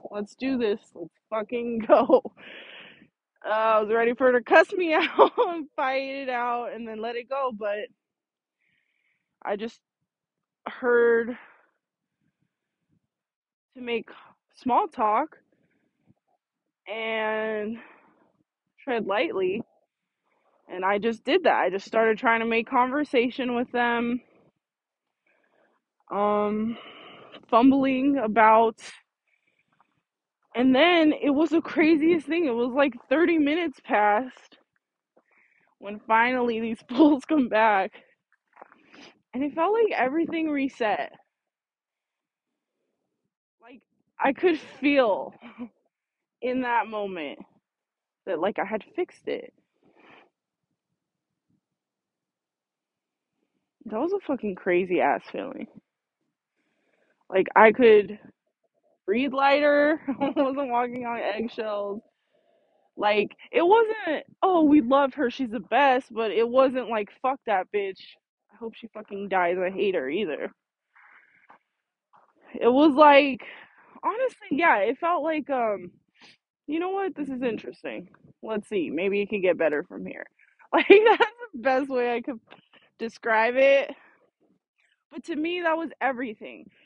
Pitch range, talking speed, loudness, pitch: 220-300 Hz, 120 wpm, -24 LUFS, 250 Hz